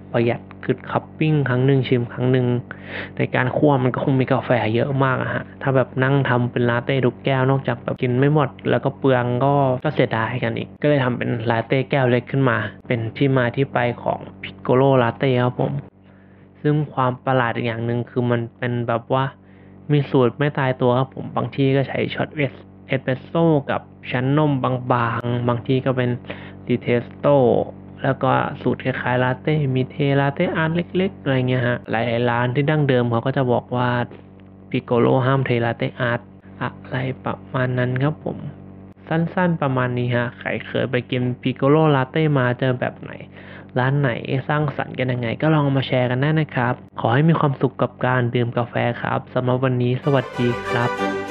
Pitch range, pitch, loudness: 120-135 Hz, 125 Hz, -20 LUFS